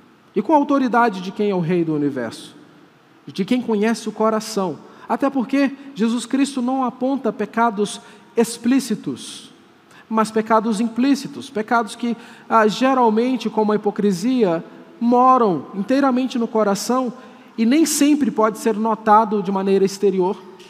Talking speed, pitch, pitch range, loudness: 135 wpm, 225 Hz, 210-255 Hz, -19 LUFS